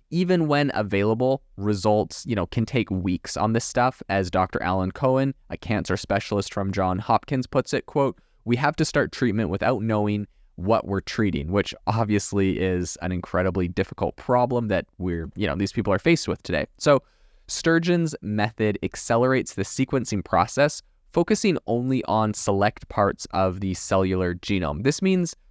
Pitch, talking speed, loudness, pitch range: 105 Hz, 165 wpm, -24 LUFS, 95-130 Hz